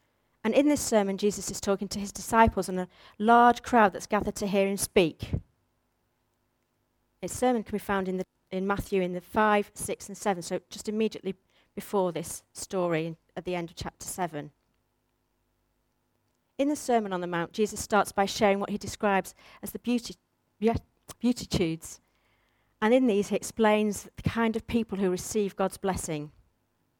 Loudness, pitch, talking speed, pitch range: -28 LUFS, 195 Hz, 170 wpm, 165-215 Hz